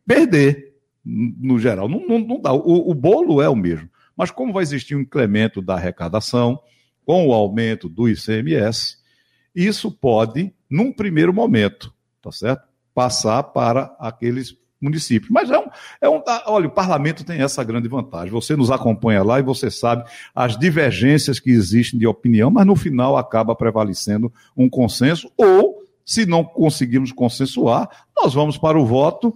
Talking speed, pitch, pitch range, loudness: 160 wpm, 130 Hz, 115-160 Hz, -18 LUFS